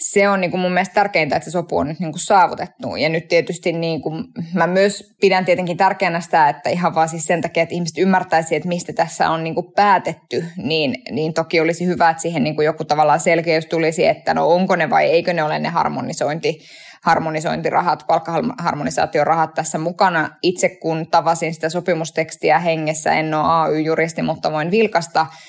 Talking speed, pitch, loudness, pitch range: 180 wpm, 165 Hz, -18 LUFS, 160-180 Hz